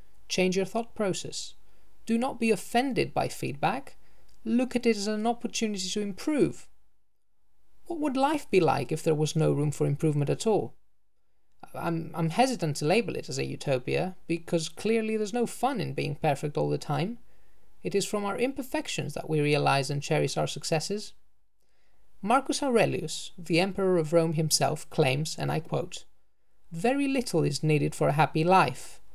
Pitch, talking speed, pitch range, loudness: 180 Hz, 170 wpm, 155-230 Hz, -28 LUFS